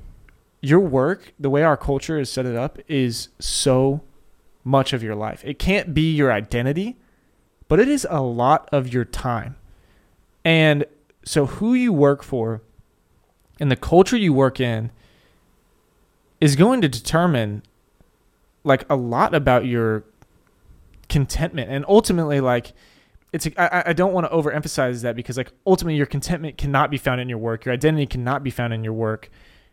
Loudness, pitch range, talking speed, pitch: -20 LUFS, 120-155 Hz, 165 wpm, 135 Hz